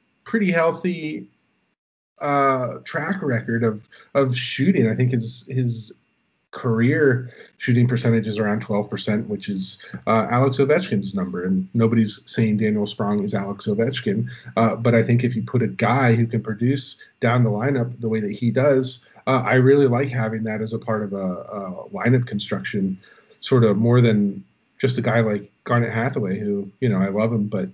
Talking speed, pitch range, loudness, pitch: 180 wpm, 105-130 Hz, -21 LUFS, 115 Hz